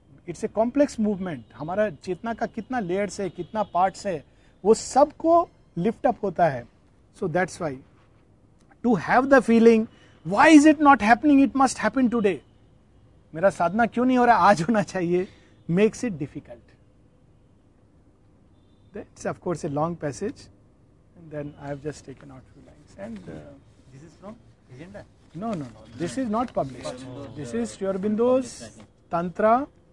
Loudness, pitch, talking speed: -23 LUFS, 180 Hz, 135 wpm